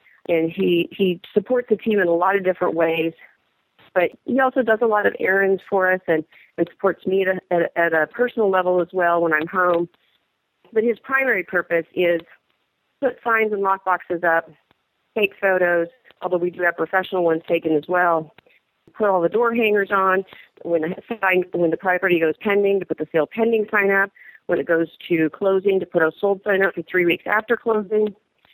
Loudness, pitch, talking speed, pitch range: -20 LUFS, 185 Hz, 205 wpm, 170-205 Hz